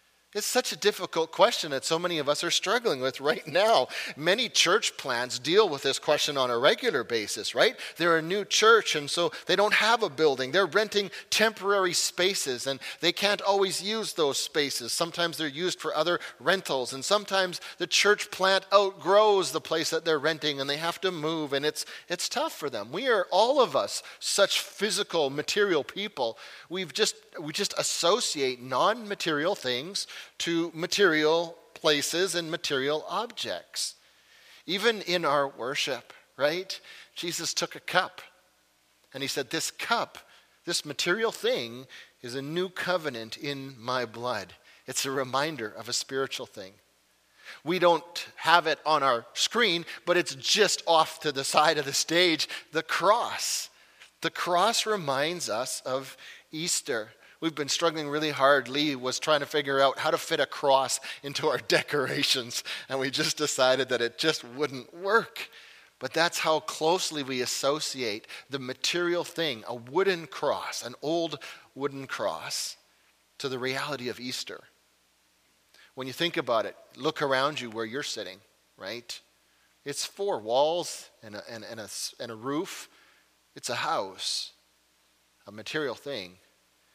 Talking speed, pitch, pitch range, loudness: 160 wpm, 155 Hz, 135-175 Hz, -27 LUFS